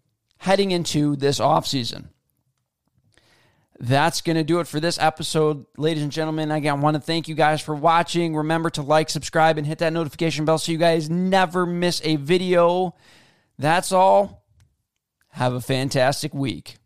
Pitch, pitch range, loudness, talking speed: 155 Hz, 140-170 Hz, -21 LUFS, 165 wpm